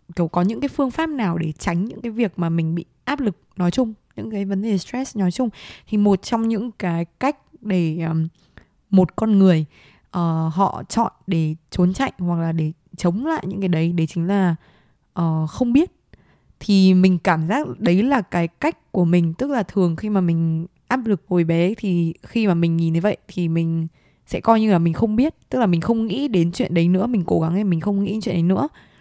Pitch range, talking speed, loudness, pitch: 170-220 Hz, 235 wpm, -20 LUFS, 185 Hz